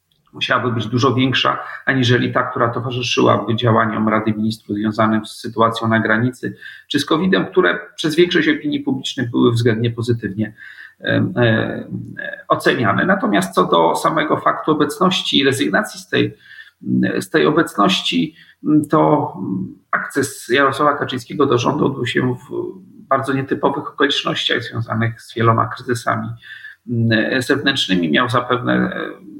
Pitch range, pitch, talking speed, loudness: 110-135 Hz, 120 Hz, 125 wpm, -17 LUFS